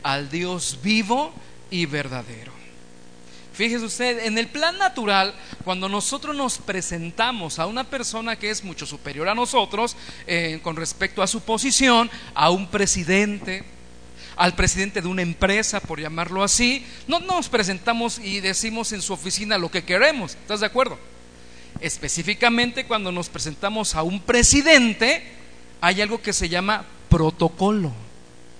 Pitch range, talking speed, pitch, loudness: 165-230 Hz, 145 wpm, 195 Hz, -21 LUFS